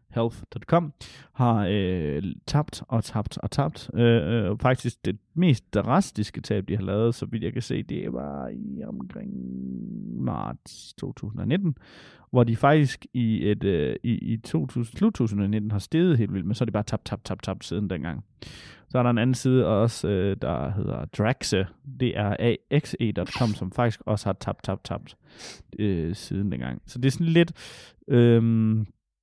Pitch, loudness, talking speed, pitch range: 115 Hz, -26 LUFS, 170 wpm, 100-125 Hz